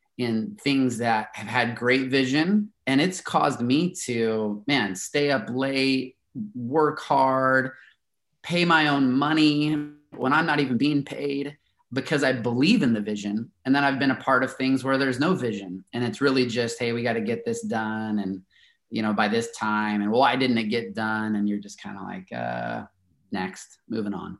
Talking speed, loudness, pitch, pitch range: 195 wpm, -24 LUFS, 130 Hz, 110-145 Hz